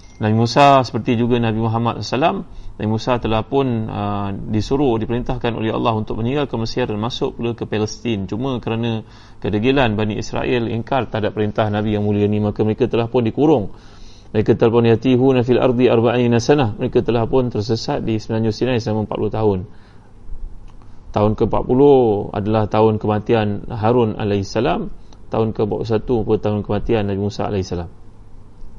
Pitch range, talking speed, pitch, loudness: 105-120 Hz, 160 wpm, 110 Hz, -18 LUFS